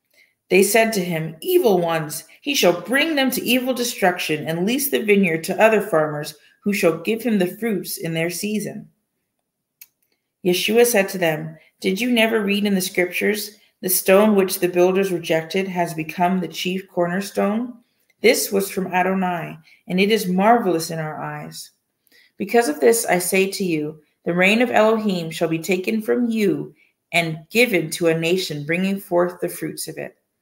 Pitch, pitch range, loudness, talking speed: 185 Hz, 170-215 Hz, -20 LUFS, 175 wpm